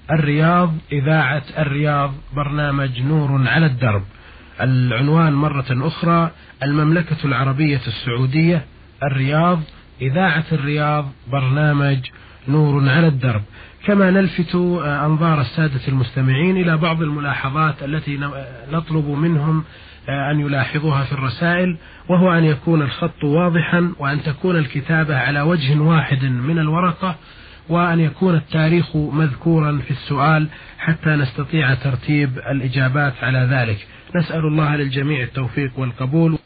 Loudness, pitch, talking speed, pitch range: -18 LUFS, 150 Hz, 105 wpm, 135-160 Hz